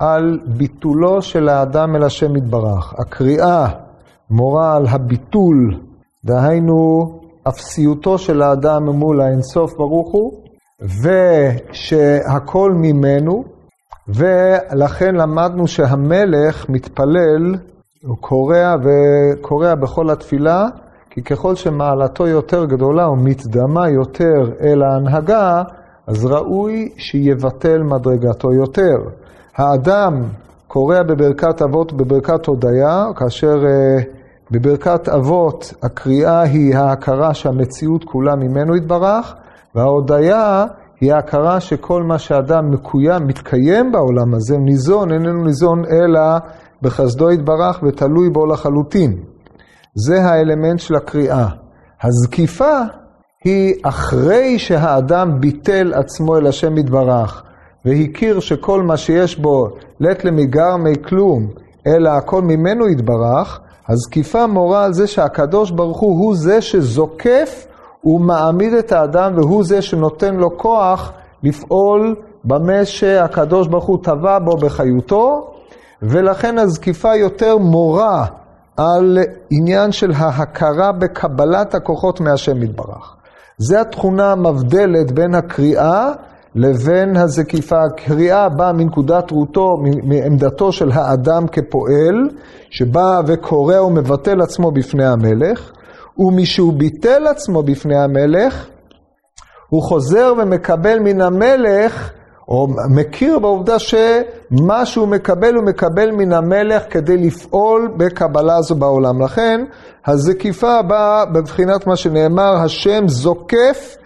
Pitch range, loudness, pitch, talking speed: 140-185 Hz, -14 LUFS, 160 Hz, 105 wpm